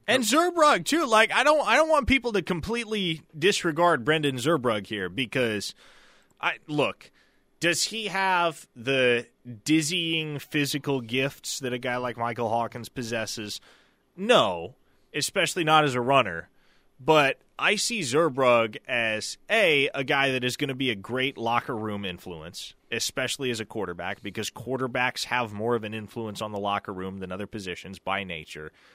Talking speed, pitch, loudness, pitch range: 160 wpm, 130 Hz, -25 LUFS, 110-170 Hz